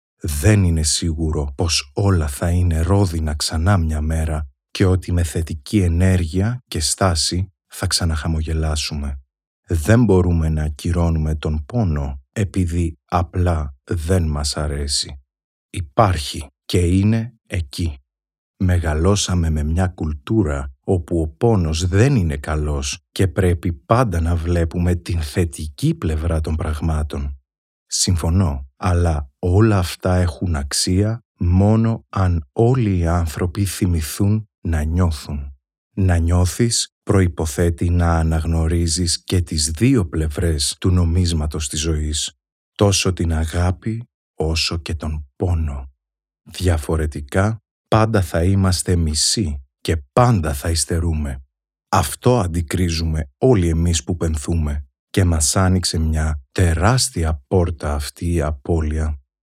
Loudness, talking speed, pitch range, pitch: -19 LUFS, 115 wpm, 80-95 Hz, 85 Hz